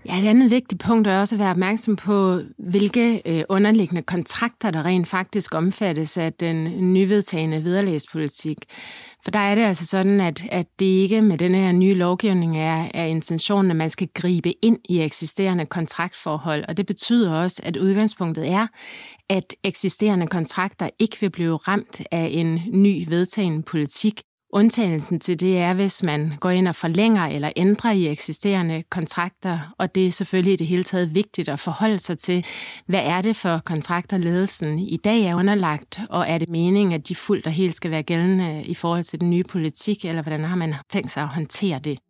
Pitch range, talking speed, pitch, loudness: 165-200 Hz, 185 wpm, 180 Hz, -21 LUFS